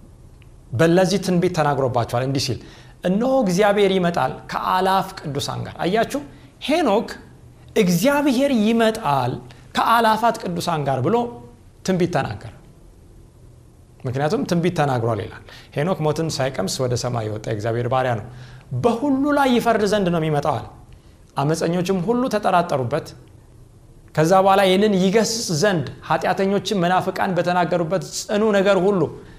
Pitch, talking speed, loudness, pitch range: 170 Hz, 110 wpm, -20 LUFS, 125-200 Hz